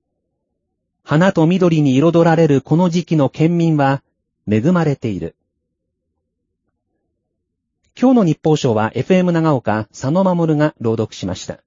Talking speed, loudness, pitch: 220 characters per minute, -15 LUFS, 140 Hz